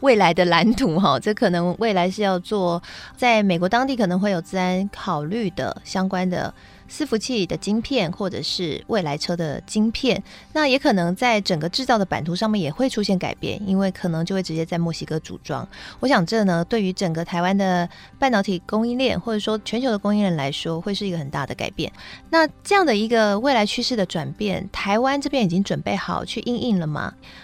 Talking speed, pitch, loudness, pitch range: 315 characters per minute, 195 Hz, -22 LUFS, 175-225 Hz